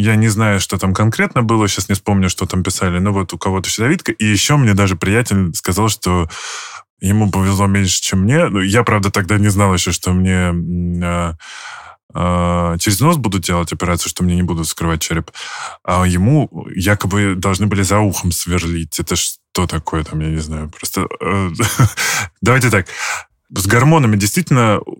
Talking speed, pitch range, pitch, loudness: 180 wpm, 90-105 Hz, 95 Hz, -15 LUFS